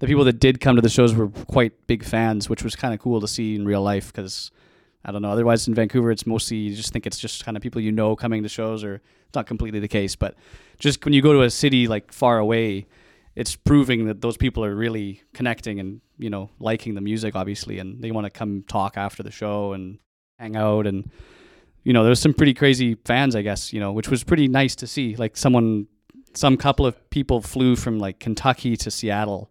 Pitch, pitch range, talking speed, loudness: 110 Hz, 105-125 Hz, 240 wpm, -21 LUFS